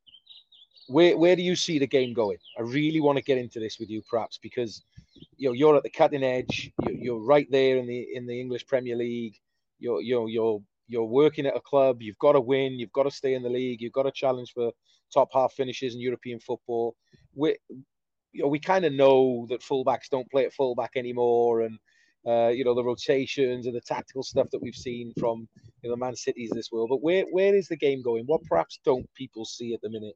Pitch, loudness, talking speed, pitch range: 125 Hz, -26 LUFS, 230 wpm, 120-135 Hz